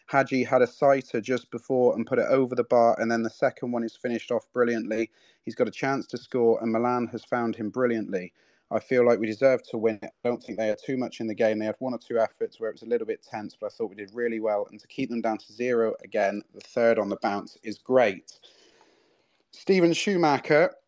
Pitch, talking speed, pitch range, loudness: 120 Hz, 255 wpm, 115-135 Hz, -26 LUFS